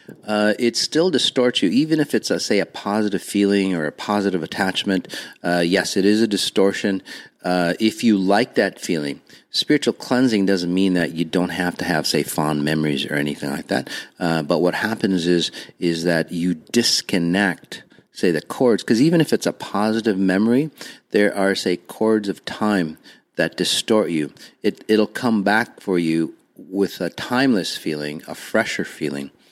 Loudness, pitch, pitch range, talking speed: -20 LUFS, 95 Hz, 85-105 Hz, 175 wpm